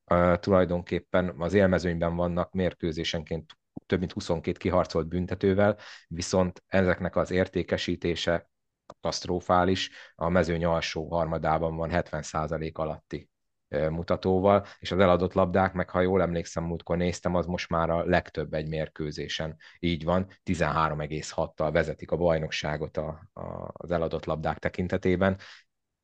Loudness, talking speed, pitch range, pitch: -28 LUFS, 115 wpm, 80-90 Hz, 85 Hz